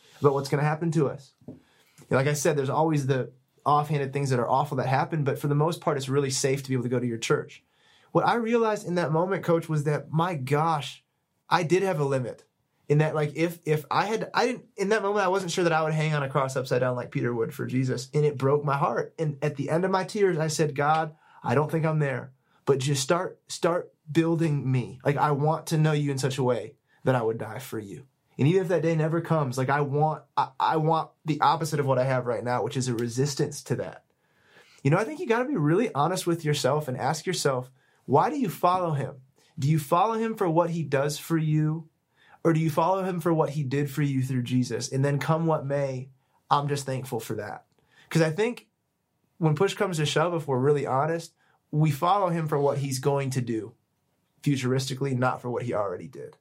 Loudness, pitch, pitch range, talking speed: -26 LUFS, 150 Hz, 135-165 Hz, 245 wpm